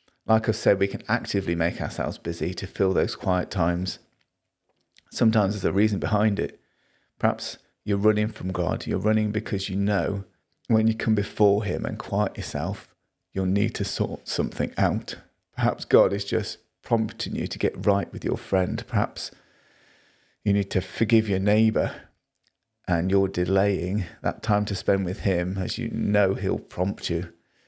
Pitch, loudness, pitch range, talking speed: 100 Hz, -25 LUFS, 95-110 Hz, 170 wpm